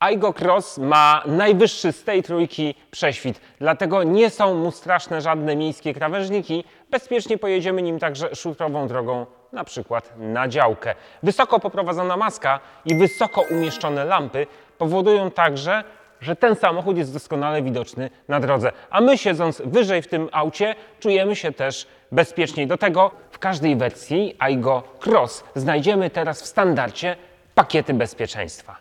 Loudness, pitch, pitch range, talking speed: -21 LUFS, 165 Hz, 140-190 Hz, 140 wpm